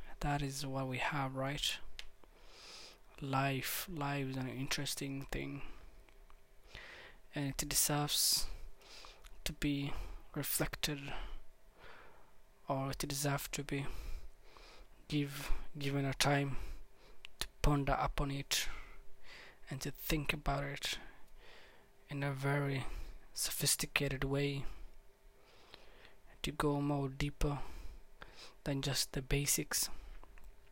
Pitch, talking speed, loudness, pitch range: 140 Hz, 95 wpm, -37 LUFS, 135-145 Hz